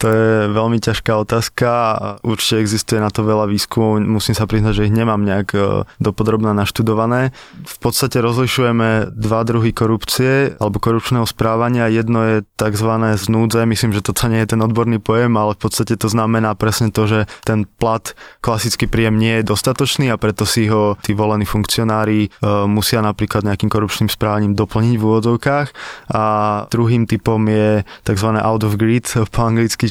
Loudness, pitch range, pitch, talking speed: -16 LUFS, 105-115 Hz, 110 Hz, 165 wpm